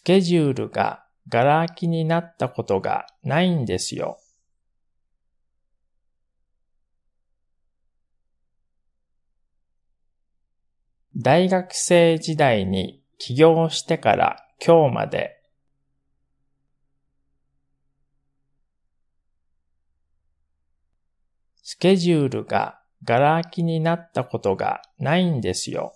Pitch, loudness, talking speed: 105 Hz, -21 LUFS, 150 characters per minute